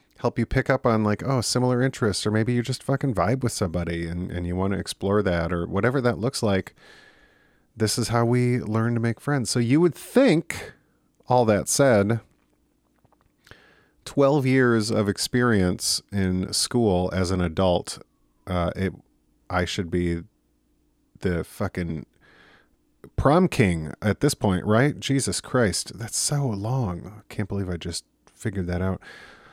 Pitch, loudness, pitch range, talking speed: 105 Hz, -24 LUFS, 90-125 Hz, 160 wpm